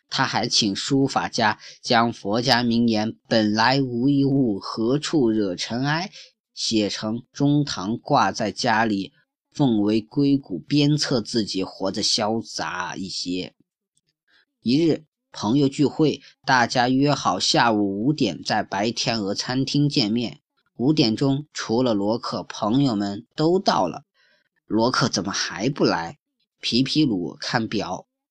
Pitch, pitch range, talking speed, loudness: 125 Hz, 110-145 Hz, 190 characters per minute, -22 LUFS